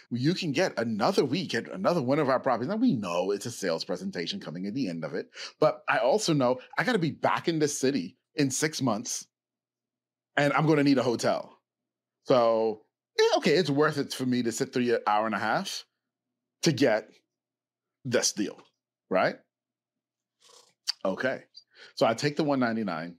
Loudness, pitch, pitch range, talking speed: -27 LUFS, 140 Hz, 115-155 Hz, 195 wpm